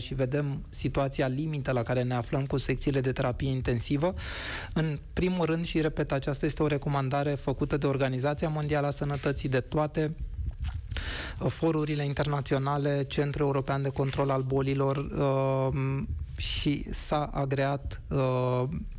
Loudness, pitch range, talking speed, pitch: -30 LUFS, 130-150 Hz, 135 wpm, 140 Hz